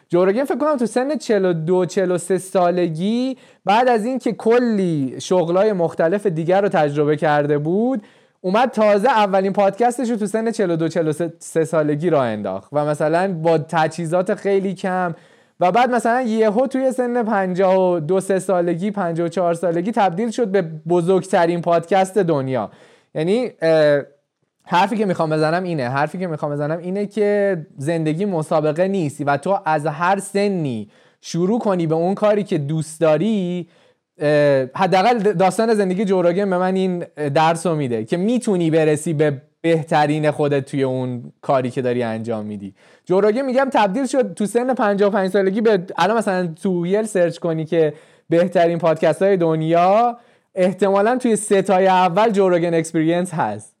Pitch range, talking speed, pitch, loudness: 160-205 Hz, 145 wpm, 180 Hz, -18 LUFS